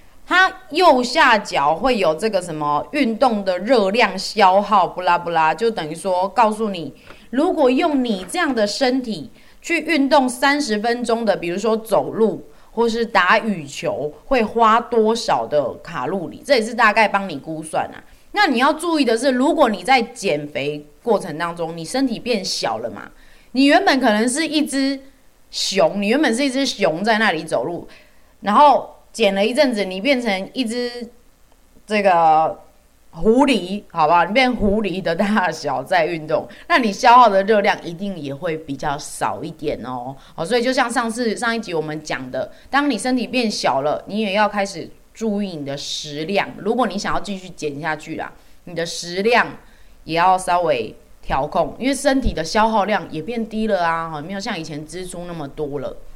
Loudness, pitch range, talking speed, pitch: -18 LUFS, 170-255 Hz, 260 characters per minute, 215 Hz